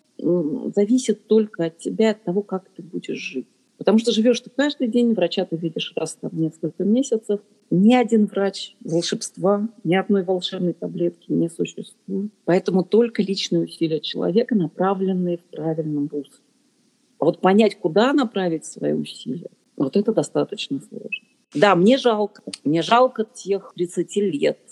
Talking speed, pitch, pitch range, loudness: 150 wpm, 200 Hz, 175-220 Hz, -21 LUFS